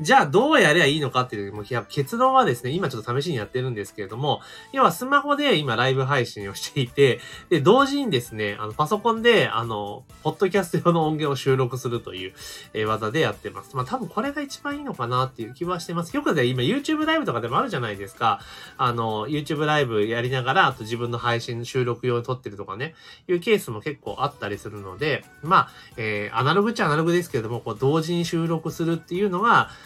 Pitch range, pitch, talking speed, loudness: 115-175 Hz, 135 Hz, 490 characters per minute, -23 LUFS